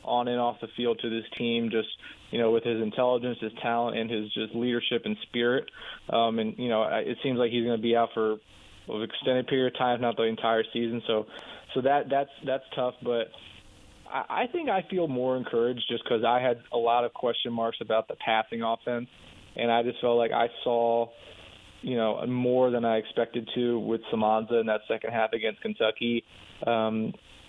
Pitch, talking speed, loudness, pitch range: 115 Hz, 205 wpm, -28 LUFS, 115-120 Hz